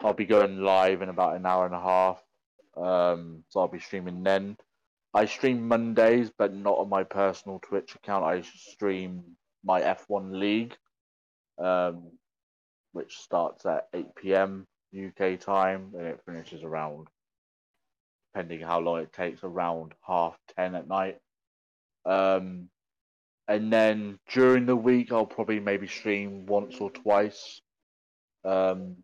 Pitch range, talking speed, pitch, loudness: 90-100 Hz, 140 wpm, 95 Hz, -27 LUFS